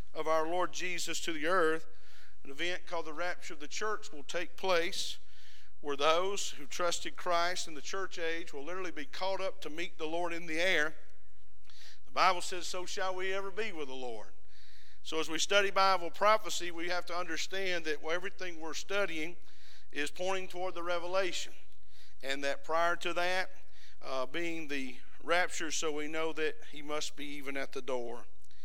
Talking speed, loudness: 185 wpm, -35 LUFS